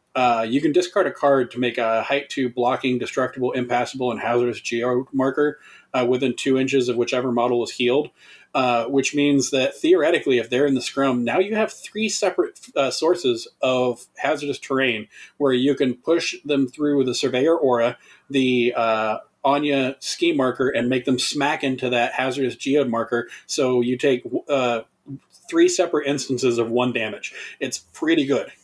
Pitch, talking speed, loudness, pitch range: 130 Hz, 175 wpm, -21 LUFS, 125-145 Hz